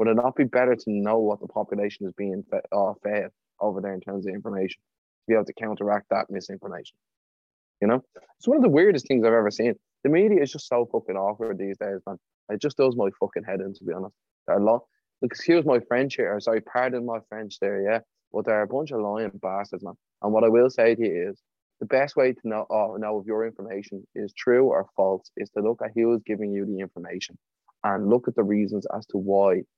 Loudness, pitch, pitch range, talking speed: -25 LUFS, 105 Hz, 100-115 Hz, 240 wpm